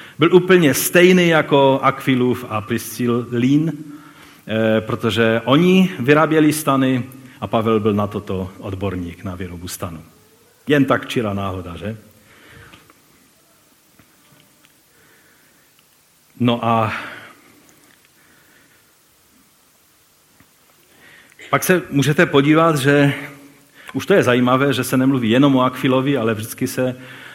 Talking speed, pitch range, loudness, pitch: 100 wpm, 110-145 Hz, -17 LUFS, 130 Hz